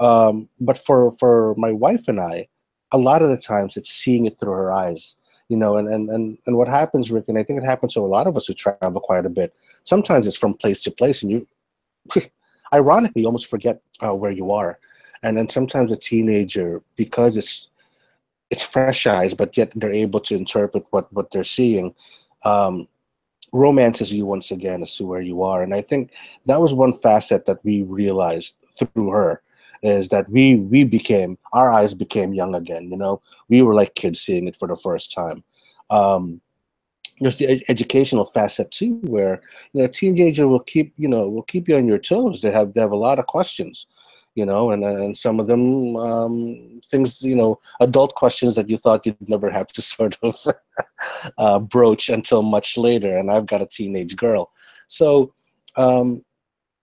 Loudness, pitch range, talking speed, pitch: -19 LUFS, 100-130 Hz, 195 wpm, 115 Hz